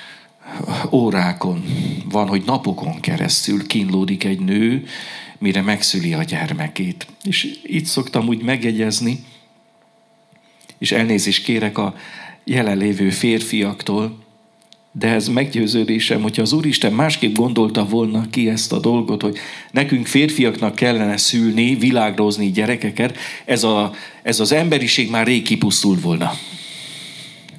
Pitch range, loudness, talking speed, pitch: 110-155 Hz, -18 LUFS, 115 wpm, 115 Hz